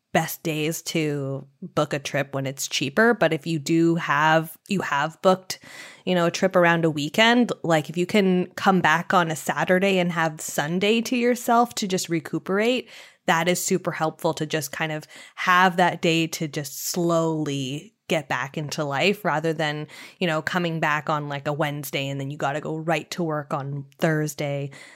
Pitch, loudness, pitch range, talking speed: 165 Hz, -23 LUFS, 150-180 Hz, 190 wpm